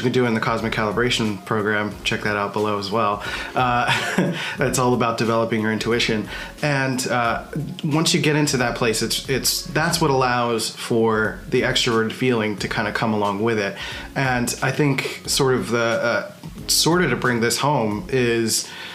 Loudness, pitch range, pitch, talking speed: -20 LUFS, 110-135 Hz, 120 Hz, 190 wpm